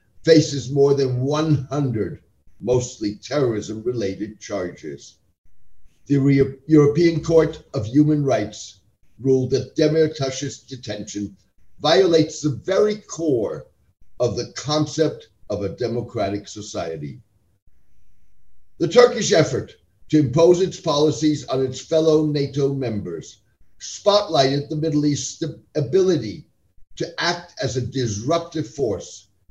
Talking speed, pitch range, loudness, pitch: 110 wpm, 110-155 Hz, -21 LUFS, 140 Hz